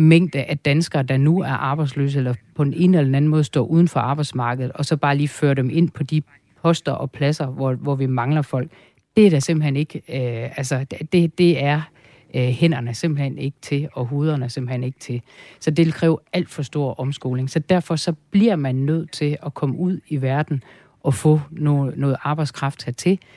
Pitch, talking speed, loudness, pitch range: 145 Hz, 210 wpm, -20 LUFS, 135-160 Hz